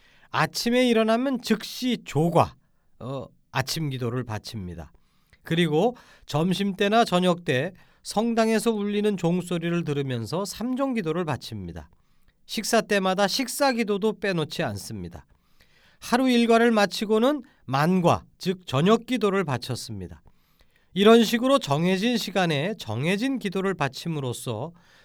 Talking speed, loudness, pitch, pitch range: 280 characters per minute, -24 LUFS, 185 Hz, 135-225 Hz